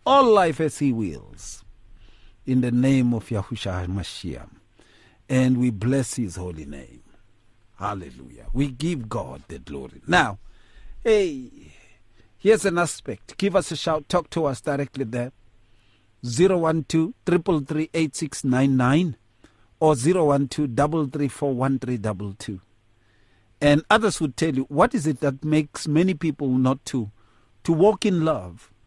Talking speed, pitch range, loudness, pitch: 140 wpm, 110-155 Hz, -23 LUFS, 130 Hz